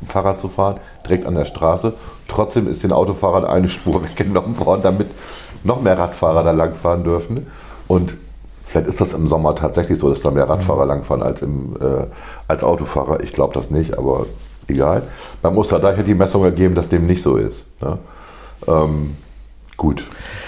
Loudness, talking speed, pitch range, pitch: -17 LUFS, 175 wpm, 80-95 Hz, 90 Hz